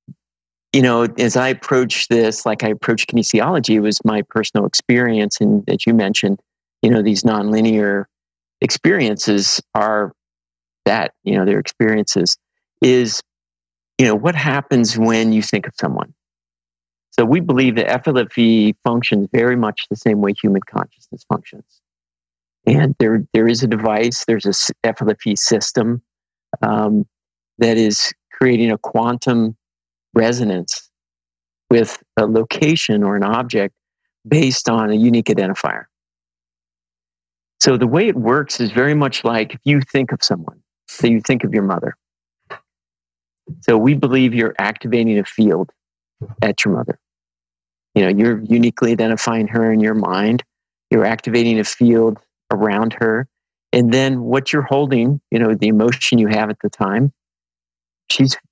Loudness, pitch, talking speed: -16 LUFS, 110 Hz, 145 wpm